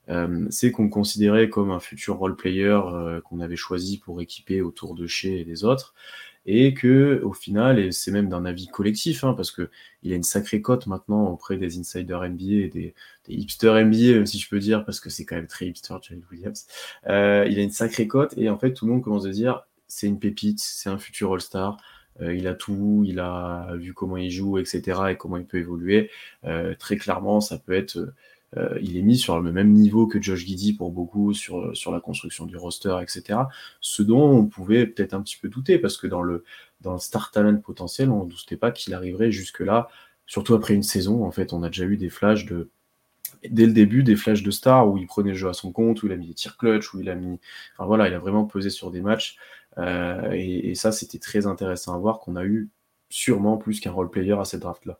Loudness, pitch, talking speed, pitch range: -23 LUFS, 100 Hz, 240 wpm, 90-105 Hz